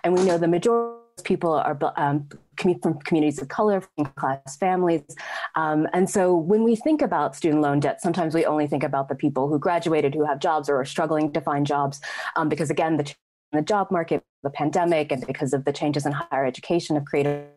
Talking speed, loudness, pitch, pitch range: 215 wpm, -23 LUFS, 155 Hz, 145-175 Hz